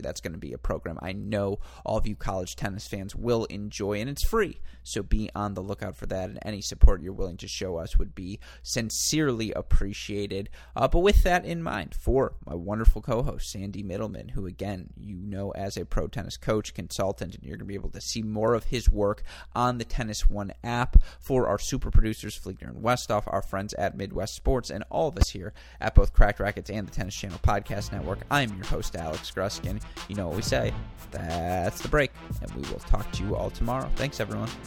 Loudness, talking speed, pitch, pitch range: -29 LUFS, 220 wpm, 100 Hz, 95-110 Hz